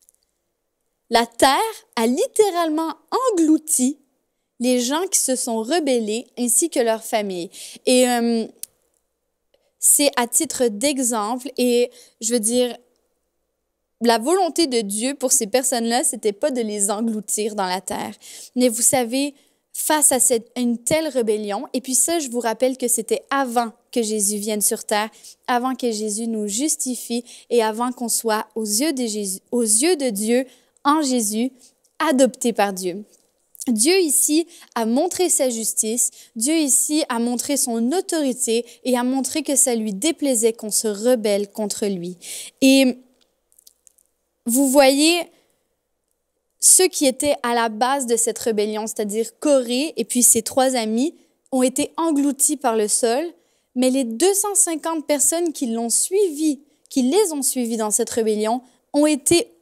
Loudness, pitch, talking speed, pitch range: -19 LUFS, 250 Hz, 150 wpm, 230-300 Hz